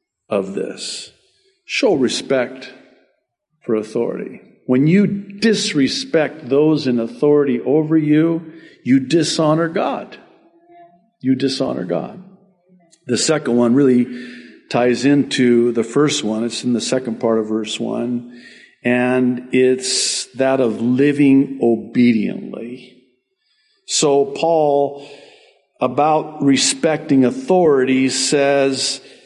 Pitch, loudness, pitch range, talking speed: 140 Hz, -17 LUFS, 125-165 Hz, 100 wpm